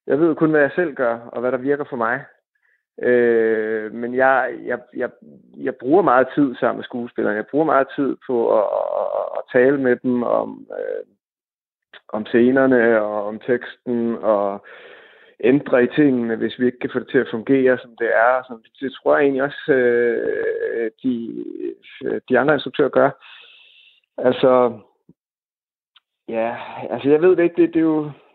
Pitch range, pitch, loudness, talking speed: 120-180 Hz, 130 Hz, -19 LUFS, 170 wpm